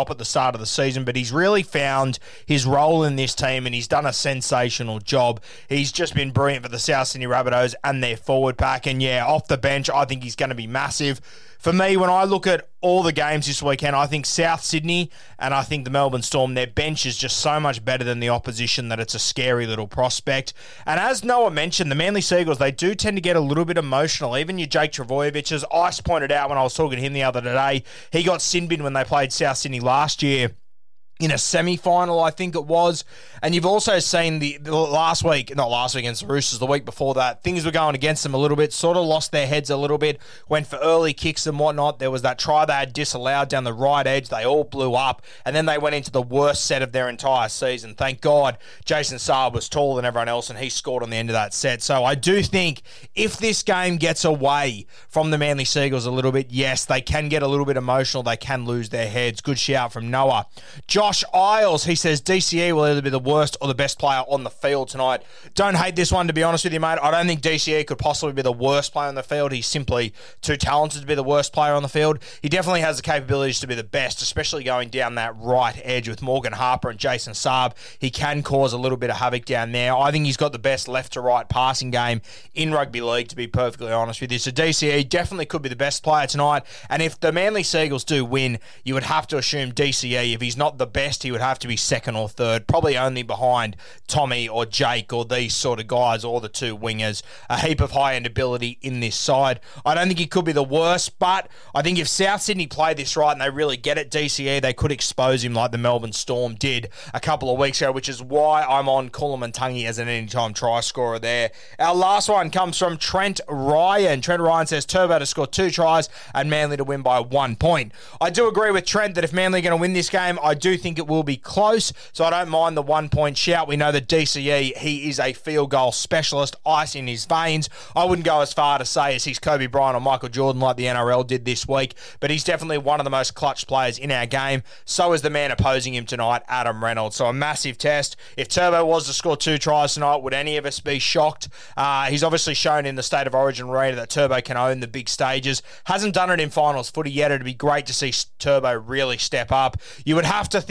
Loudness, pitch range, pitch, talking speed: -21 LUFS, 125-155 Hz, 140 Hz, 250 wpm